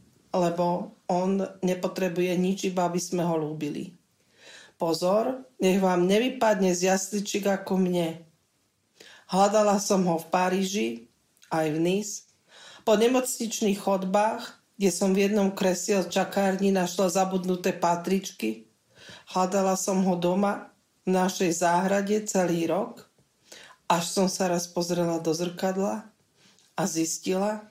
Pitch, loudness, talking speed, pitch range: 190 Hz, -26 LUFS, 120 wpm, 175-200 Hz